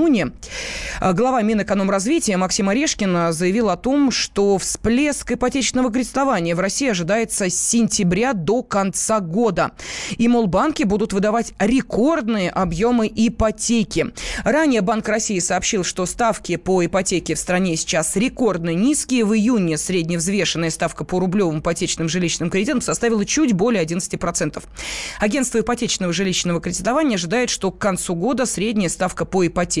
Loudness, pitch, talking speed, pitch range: -19 LUFS, 200 Hz, 135 wpm, 180-235 Hz